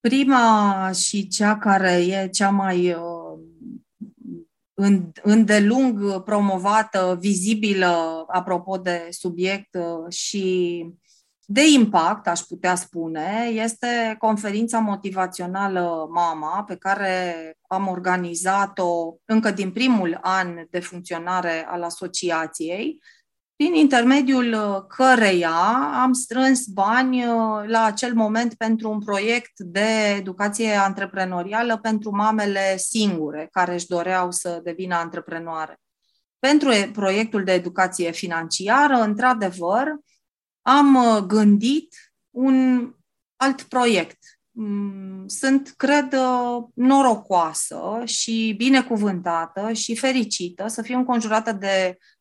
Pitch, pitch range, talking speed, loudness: 200 Hz, 180-230 Hz, 95 wpm, -21 LUFS